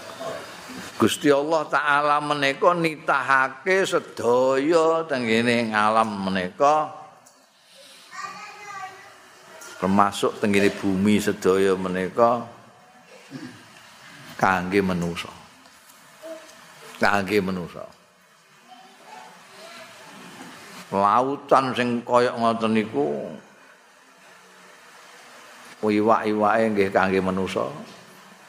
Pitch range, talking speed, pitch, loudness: 100-150 Hz, 55 wpm, 120 Hz, -22 LUFS